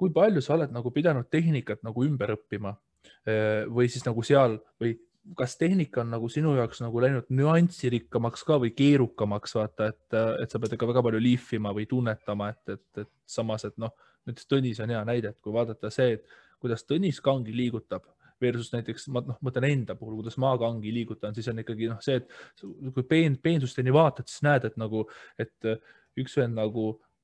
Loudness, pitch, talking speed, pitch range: -28 LUFS, 120 Hz, 185 wpm, 110-135 Hz